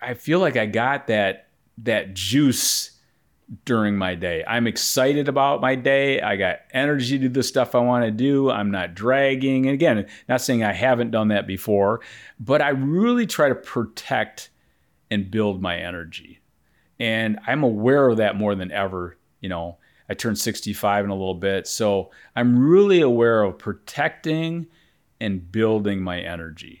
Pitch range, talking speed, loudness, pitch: 100-135 Hz, 170 wpm, -21 LUFS, 115 Hz